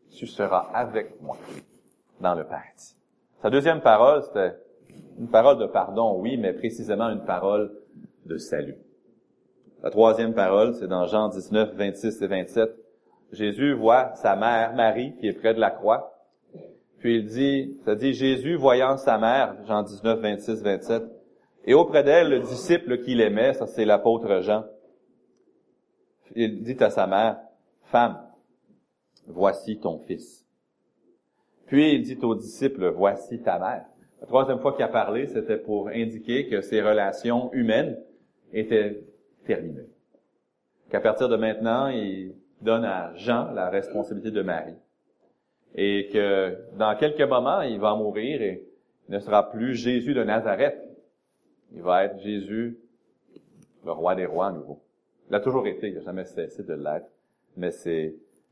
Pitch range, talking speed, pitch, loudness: 105-120 Hz, 155 wpm, 110 Hz, -24 LUFS